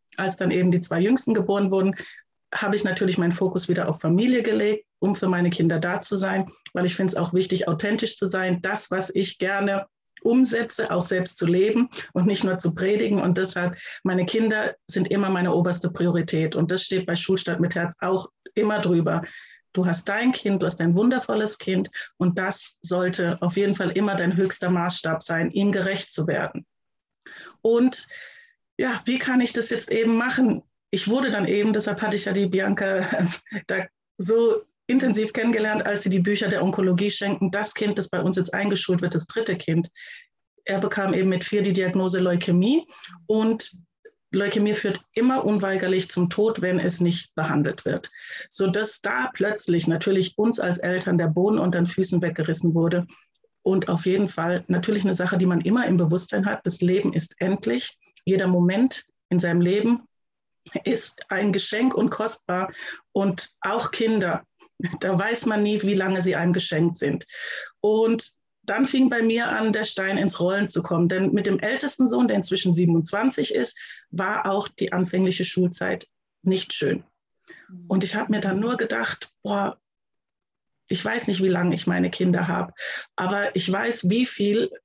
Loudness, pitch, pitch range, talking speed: -23 LUFS, 190 Hz, 180-210 Hz, 180 wpm